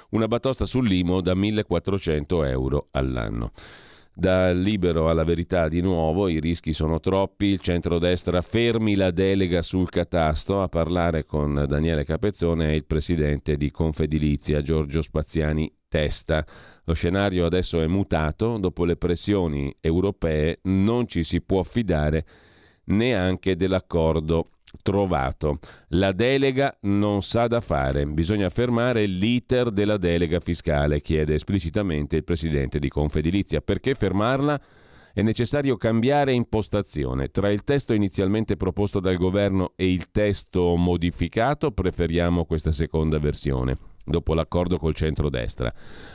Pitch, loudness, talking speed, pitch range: 90 Hz, -24 LUFS, 125 wpm, 80-100 Hz